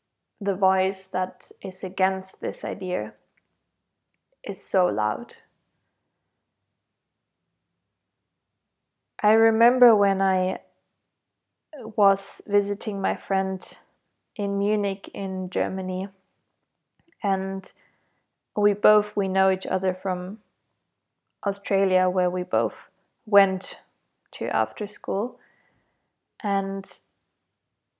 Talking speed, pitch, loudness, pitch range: 85 wpm, 195 Hz, -24 LUFS, 185-205 Hz